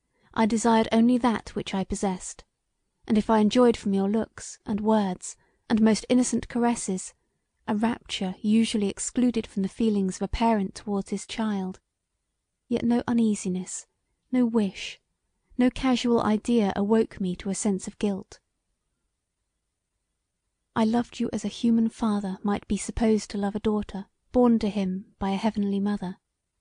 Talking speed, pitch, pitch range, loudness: 155 wpm, 220 Hz, 200-230 Hz, -26 LUFS